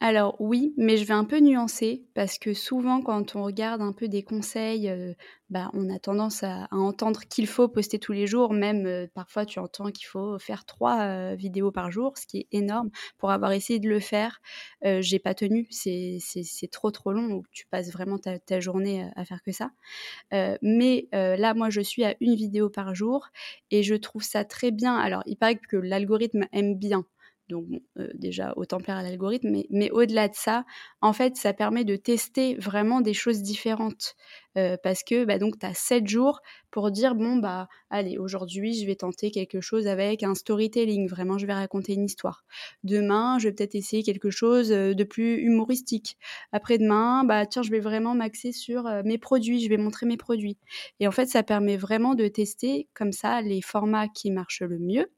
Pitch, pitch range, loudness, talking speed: 210 Hz, 195-230 Hz, -26 LUFS, 210 wpm